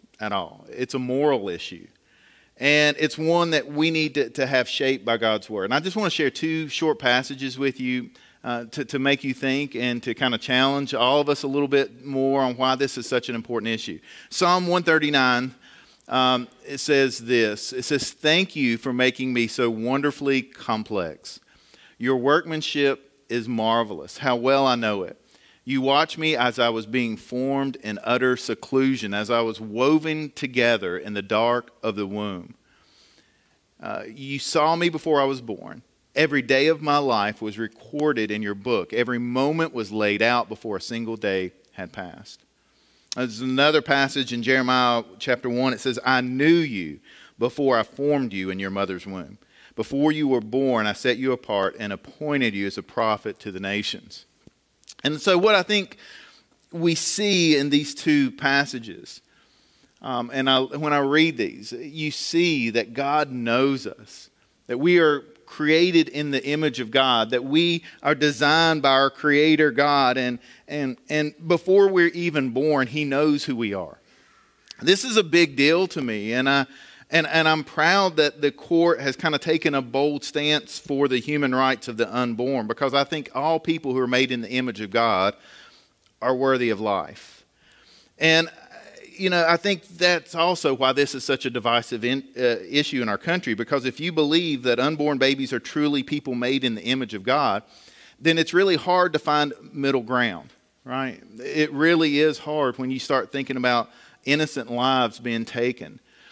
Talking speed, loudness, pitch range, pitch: 185 wpm, -22 LUFS, 120-150 Hz, 135 Hz